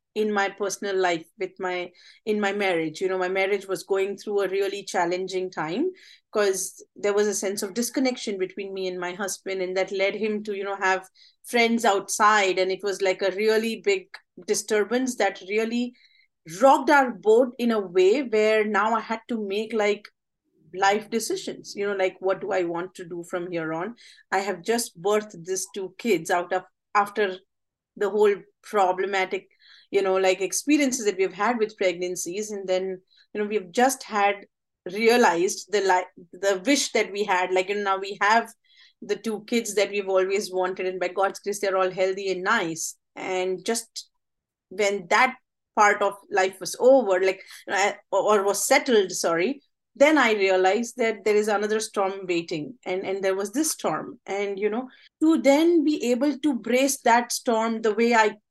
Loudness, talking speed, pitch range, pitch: -24 LUFS, 190 wpm, 190-225 Hz, 200 Hz